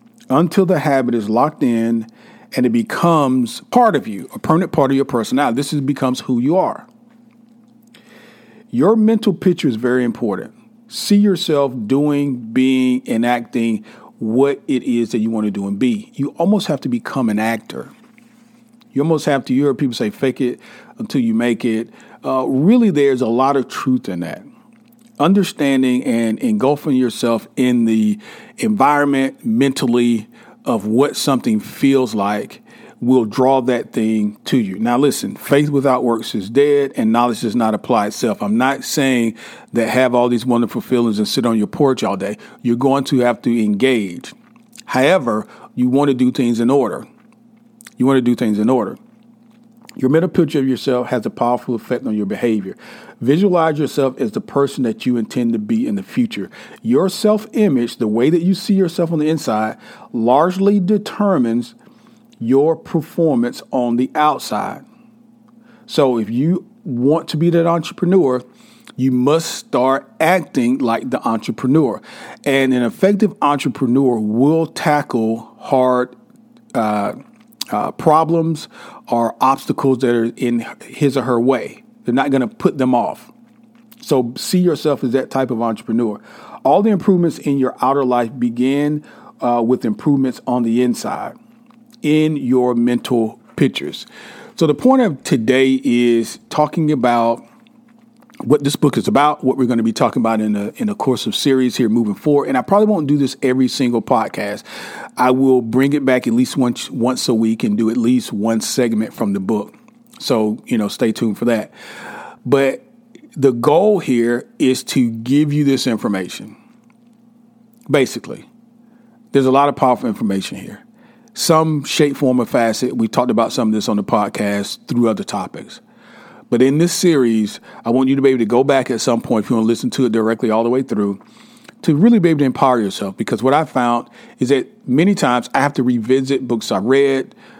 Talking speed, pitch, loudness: 175 wpm, 140 Hz, -16 LUFS